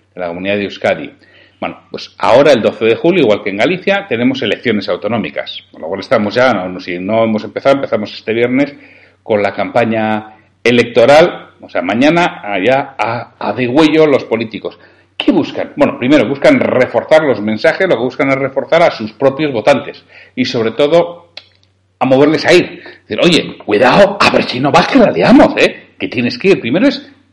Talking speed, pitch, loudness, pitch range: 190 wpm, 120 Hz, -12 LUFS, 105-145 Hz